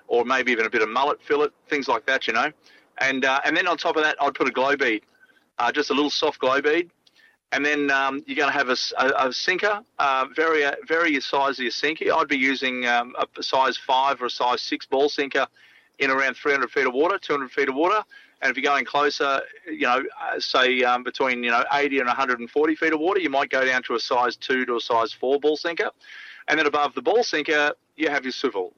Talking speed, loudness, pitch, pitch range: 250 wpm, -22 LUFS, 145 Hz, 135-170 Hz